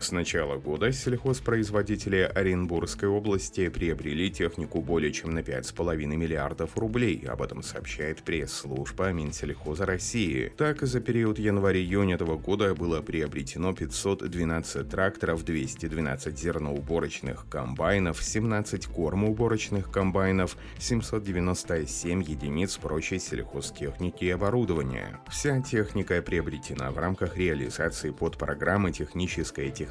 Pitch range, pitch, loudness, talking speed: 80-100 Hz, 90 Hz, -29 LUFS, 105 wpm